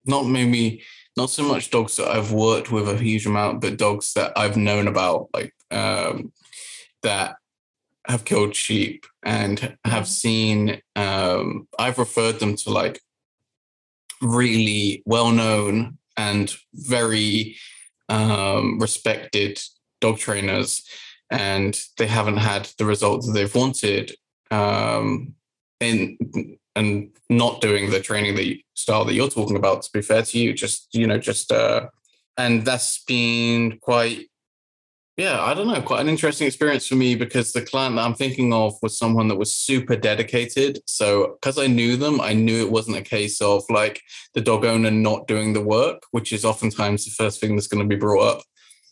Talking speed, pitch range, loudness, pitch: 165 wpm, 105-120 Hz, -21 LUFS, 110 Hz